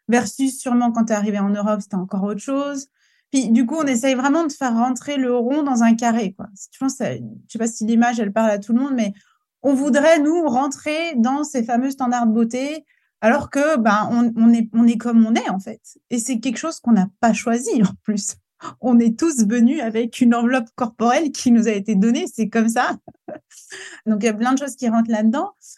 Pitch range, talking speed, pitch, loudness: 225-270 Hz, 235 wpm, 240 Hz, -19 LUFS